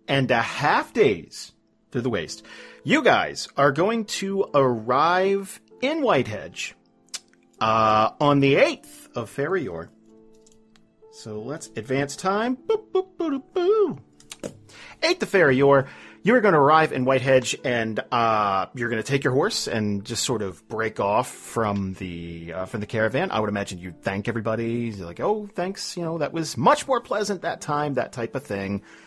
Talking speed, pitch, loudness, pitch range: 175 wpm, 125 Hz, -23 LUFS, 110-185 Hz